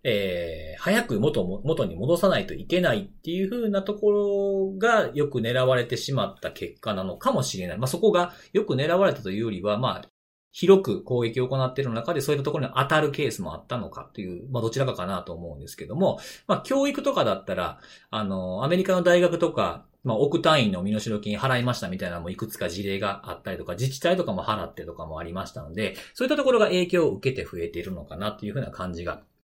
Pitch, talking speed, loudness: 130 Hz, 455 characters per minute, -25 LUFS